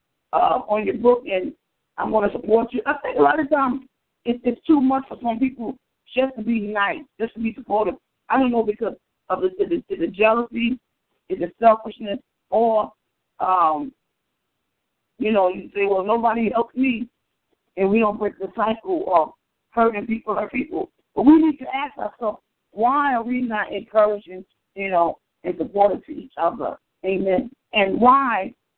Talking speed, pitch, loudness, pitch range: 175 wpm, 230 Hz, -21 LUFS, 210-265 Hz